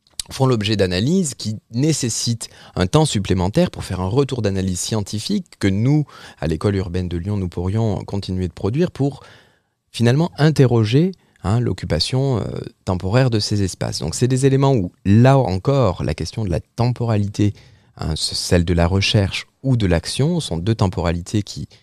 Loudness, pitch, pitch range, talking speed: -19 LUFS, 110 Hz, 95-130 Hz, 165 wpm